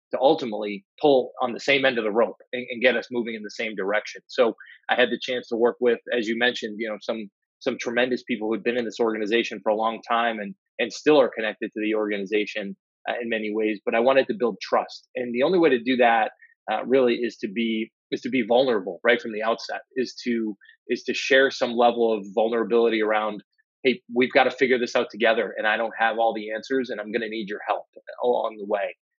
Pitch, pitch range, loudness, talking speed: 115 Hz, 110-125 Hz, -24 LUFS, 245 wpm